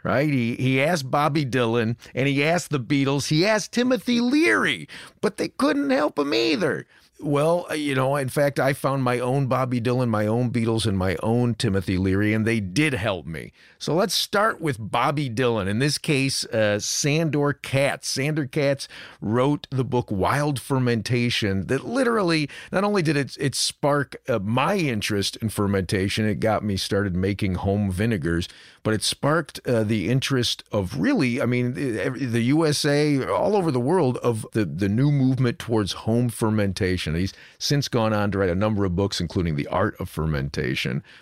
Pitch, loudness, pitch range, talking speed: 125 Hz, -23 LUFS, 105-145 Hz, 180 wpm